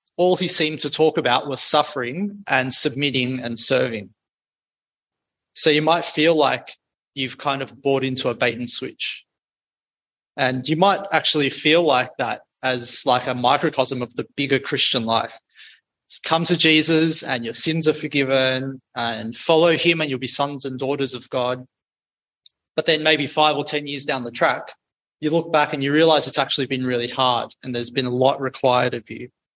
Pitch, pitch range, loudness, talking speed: 140 Hz, 130-155 Hz, -19 LUFS, 185 wpm